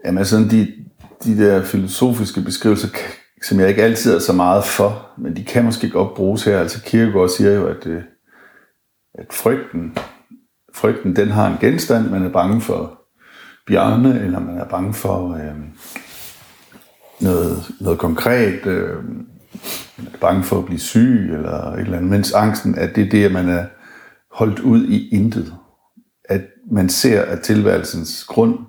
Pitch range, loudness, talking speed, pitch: 90-115 Hz, -17 LUFS, 165 wpm, 100 Hz